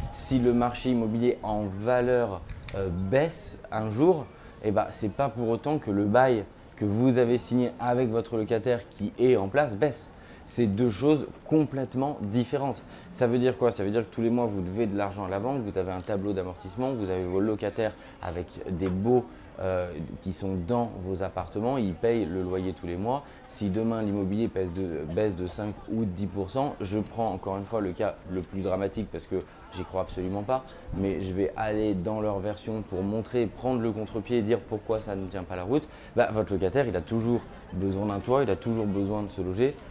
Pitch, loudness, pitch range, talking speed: 105 Hz, -28 LUFS, 95-120 Hz, 215 wpm